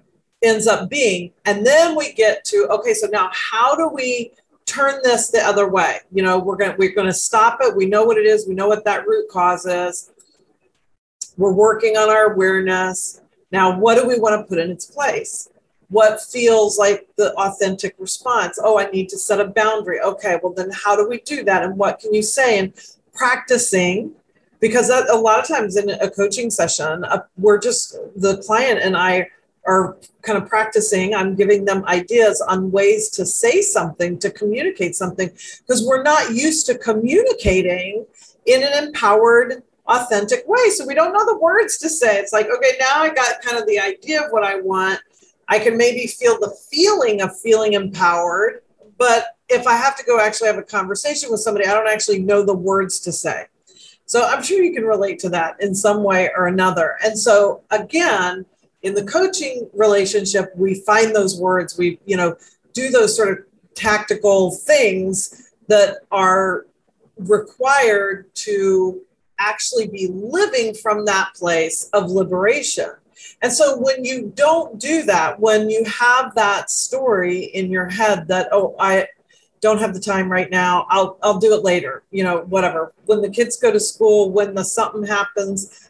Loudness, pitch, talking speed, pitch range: -17 LUFS, 210 Hz, 185 wpm, 190-245 Hz